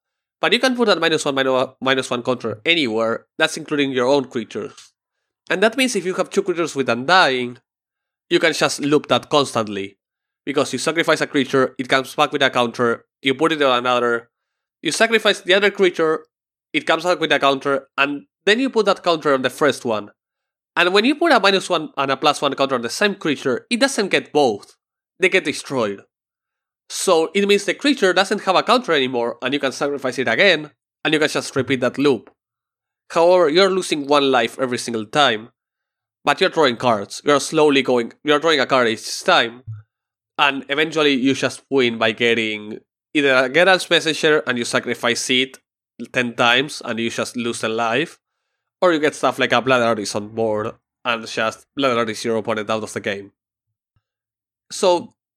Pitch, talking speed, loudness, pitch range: 140 Hz, 195 wpm, -18 LUFS, 120-165 Hz